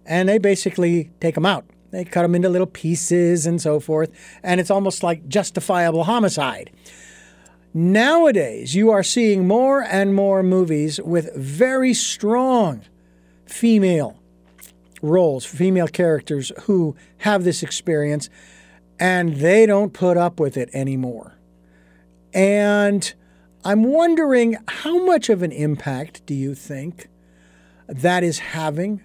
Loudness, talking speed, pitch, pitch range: -19 LUFS, 130 wpm, 175 Hz, 140-200 Hz